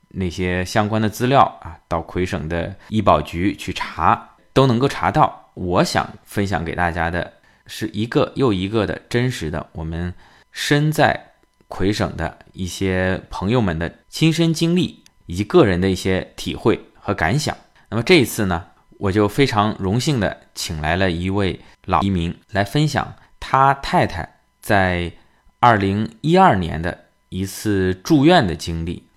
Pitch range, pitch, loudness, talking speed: 90-120 Hz, 100 Hz, -19 LUFS, 225 characters per minute